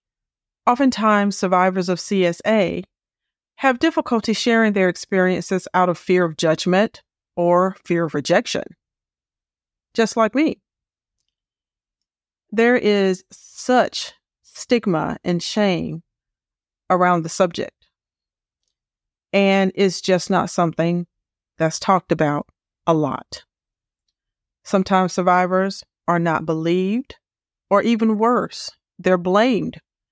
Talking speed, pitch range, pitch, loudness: 100 wpm, 170-210 Hz, 185 Hz, -19 LUFS